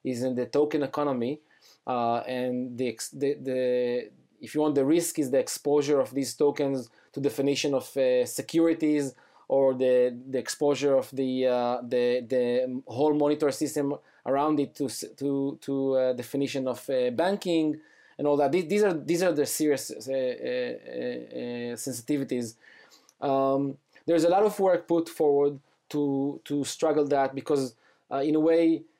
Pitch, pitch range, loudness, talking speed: 140 Hz, 130-150 Hz, -27 LUFS, 165 wpm